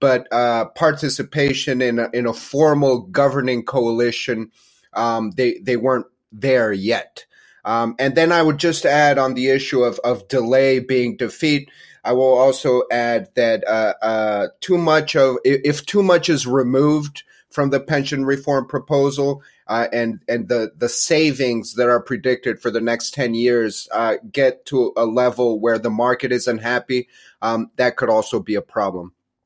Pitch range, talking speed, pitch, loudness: 120-140 Hz, 165 wpm, 130 Hz, -18 LUFS